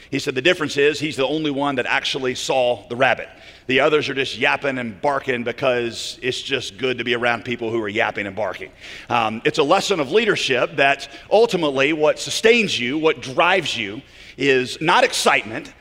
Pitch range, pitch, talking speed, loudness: 120-150 Hz, 135 Hz, 195 wpm, -19 LUFS